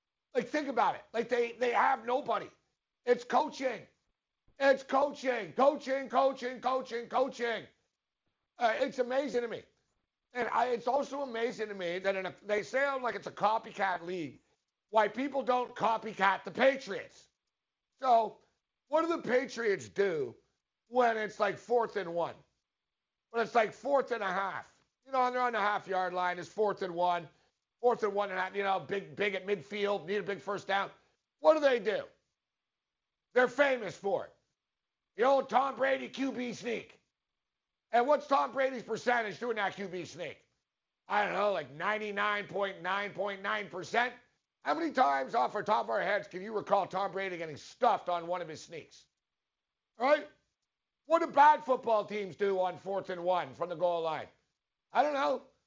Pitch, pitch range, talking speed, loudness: 220 Hz, 195-260 Hz, 175 wpm, -32 LUFS